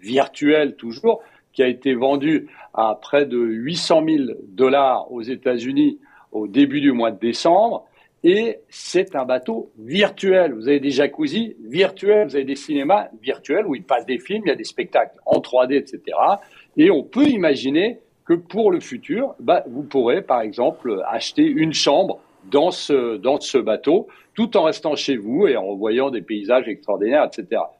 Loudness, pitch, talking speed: -19 LUFS, 200 Hz, 175 wpm